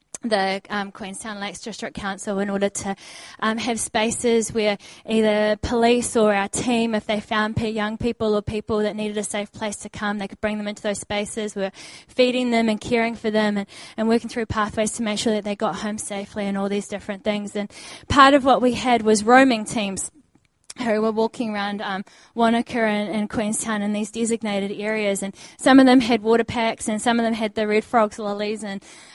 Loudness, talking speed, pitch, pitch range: -22 LUFS, 210 wpm, 215 Hz, 205-230 Hz